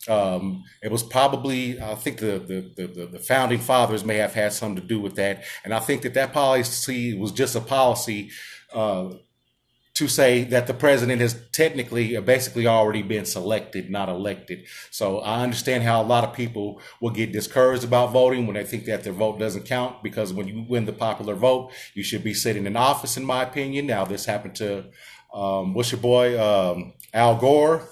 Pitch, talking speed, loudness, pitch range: 115 Hz, 200 wpm, -23 LUFS, 105-125 Hz